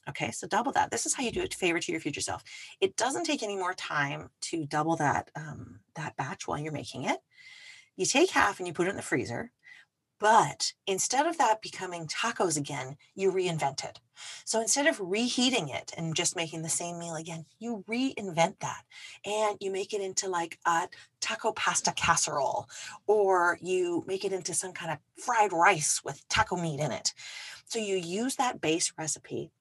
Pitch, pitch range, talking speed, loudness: 185 Hz, 165-225 Hz, 200 wpm, -29 LUFS